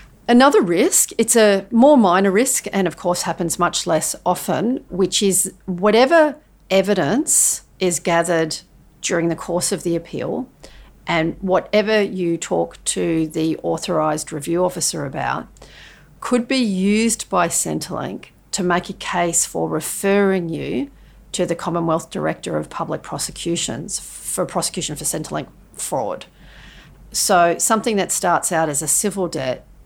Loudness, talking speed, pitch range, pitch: -19 LUFS, 140 wpm, 165-205 Hz, 180 Hz